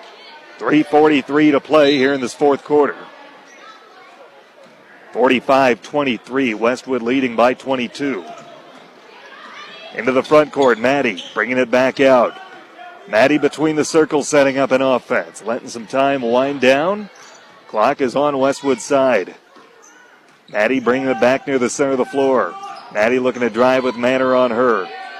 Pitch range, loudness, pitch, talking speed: 130-145 Hz, -16 LUFS, 135 Hz, 140 wpm